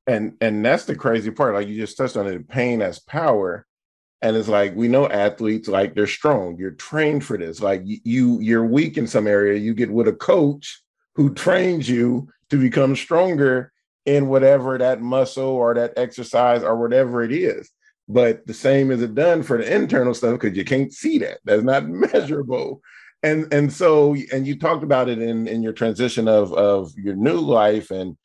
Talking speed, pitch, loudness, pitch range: 200 wpm, 120 Hz, -19 LUFS, 110-140 Hz